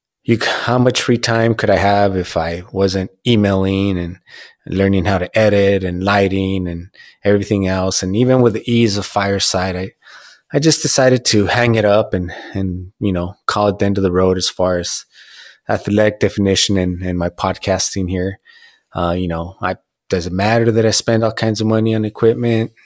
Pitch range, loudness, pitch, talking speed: 95-110 Hz, -16 LUFS, 100 Hz, 190 wpm